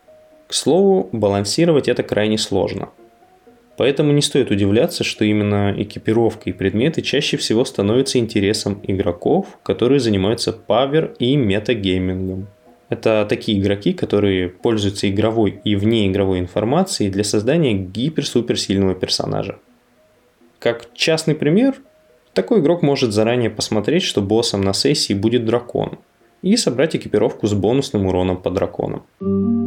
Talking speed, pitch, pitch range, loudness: 125 wpm, 115 Hz, 100-135 Hz, -18 LUFS